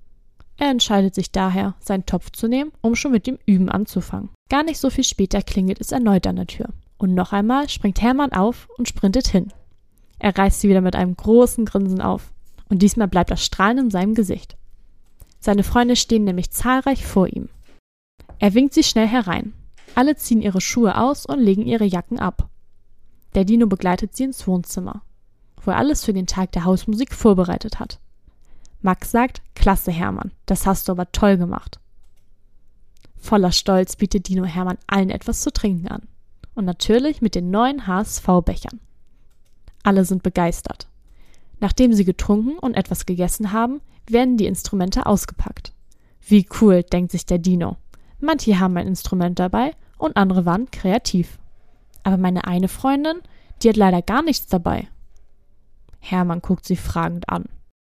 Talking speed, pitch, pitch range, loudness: 165 wpm, 195 Hz, 180-230 Hz, -19 LUFS